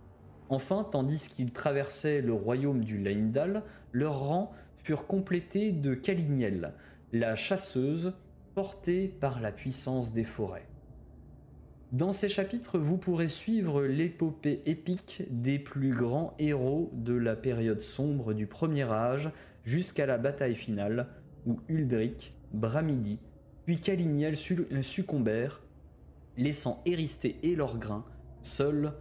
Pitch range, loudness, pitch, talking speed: 115-165 Hz, -32 LUFS, 140 Hz, 120 wpm